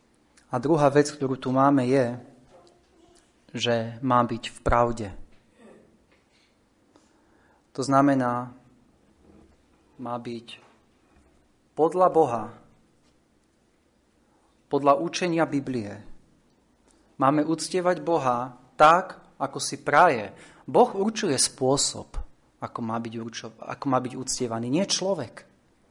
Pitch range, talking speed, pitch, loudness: 120-155 Hz, 95 wpm, 130 Hz, -24 LUFS